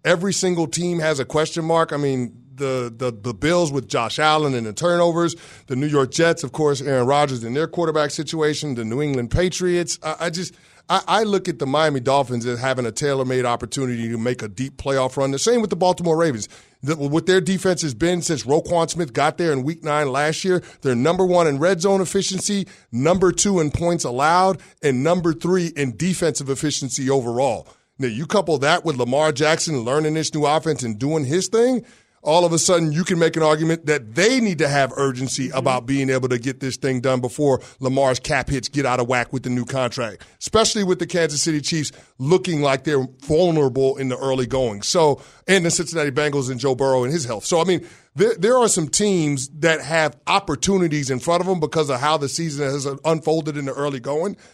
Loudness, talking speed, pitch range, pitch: -20 LUFS, 220 wpm, 135-170 Hz, 150 Hz